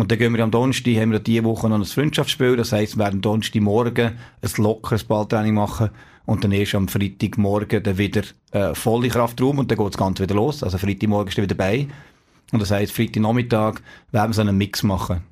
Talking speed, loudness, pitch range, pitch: 215 wpm, -20 LUFS, 105-115 Hz, 110 Hz